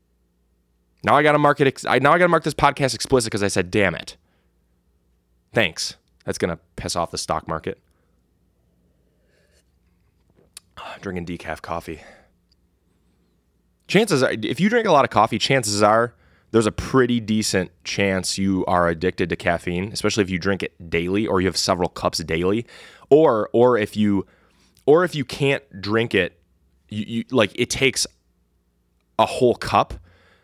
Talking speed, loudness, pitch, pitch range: 160 wpm, -20 LUFS, 90 Hz, 80-110 Hz